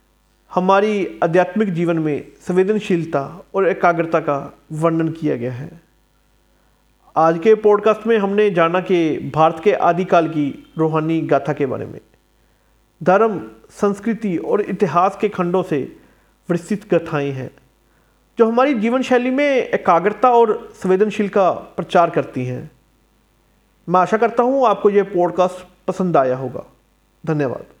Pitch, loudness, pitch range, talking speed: 180 Hz, -18 LUFS, 155-210 Hz, 130 wpm